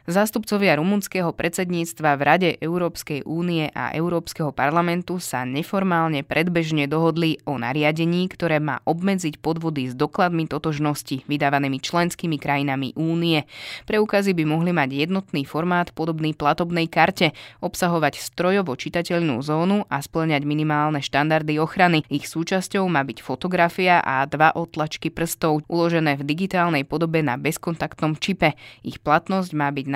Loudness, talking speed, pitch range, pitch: -22 LUFS, 130 wpm, 145-175 Hz, 160 Hz